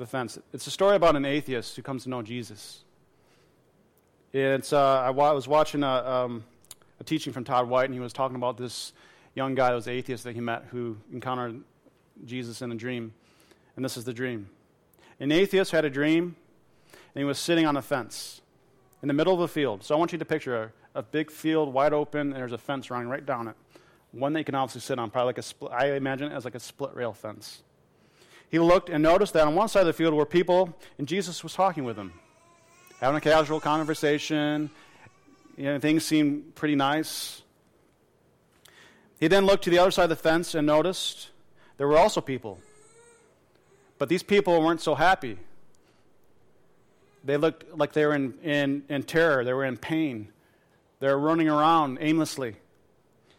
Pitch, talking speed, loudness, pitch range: 145 Hz, 200 wpm, -26 LUFS, 125-160 Hz